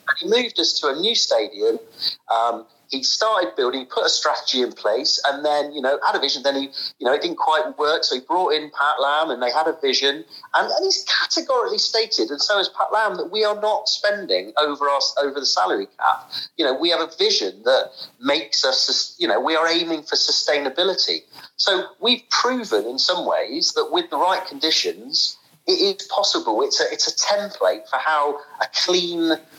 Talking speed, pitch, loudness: 210 wpm, 180 Hz, -20 LUFS